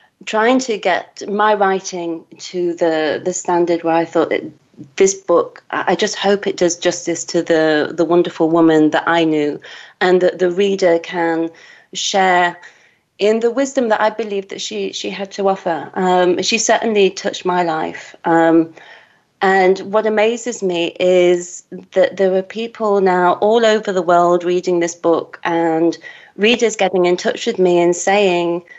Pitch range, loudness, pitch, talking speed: 170-205 Hz, -16 LUFS, 180 Hz, 165 wpm